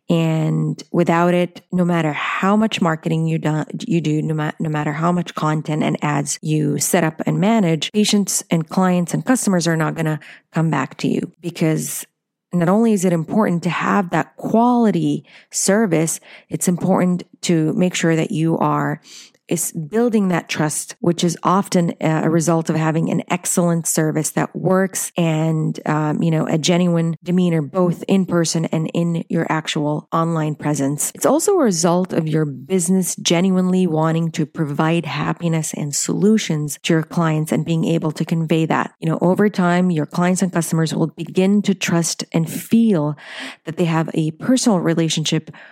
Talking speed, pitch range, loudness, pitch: 175 wpm, 160-185 Hz, -18 LUFS, 170 Hz